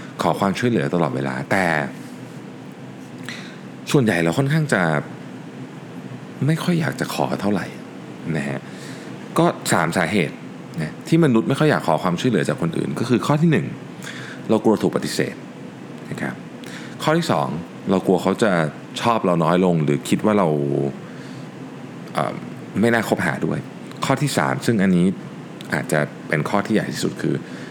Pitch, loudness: 105 Hz, -21 LUFS